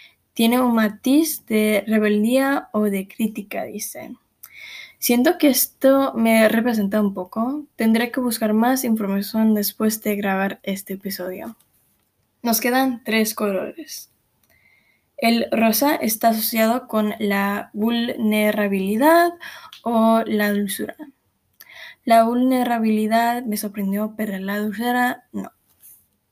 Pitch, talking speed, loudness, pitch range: 225 Hz, 110 wpm, -20 LUFS, 210-250 Hz